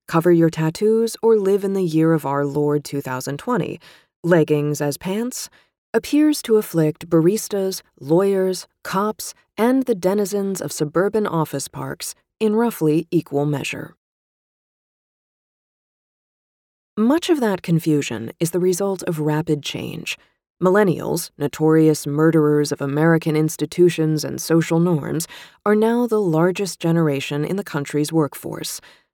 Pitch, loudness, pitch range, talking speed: 165 Hz, -20 LUFS, 150-195 Hz, 125 wpm